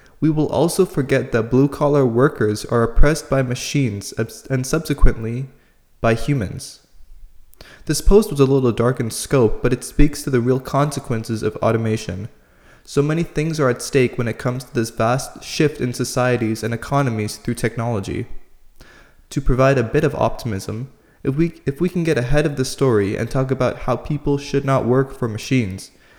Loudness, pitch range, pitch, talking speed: -20 LUFS, 115-145 Hz, 130 Hz, 180 wpm